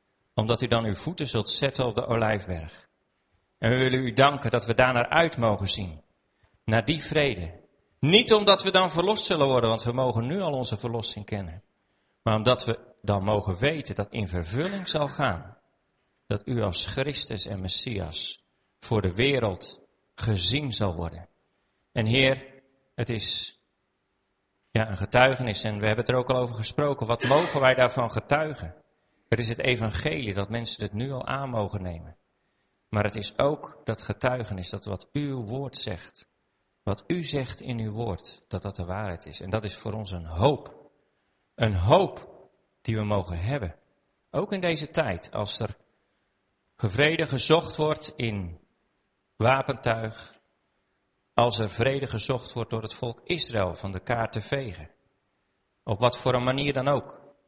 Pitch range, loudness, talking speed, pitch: 100-135 Hz, -26 LUFS, 170 wpm, 115 Hz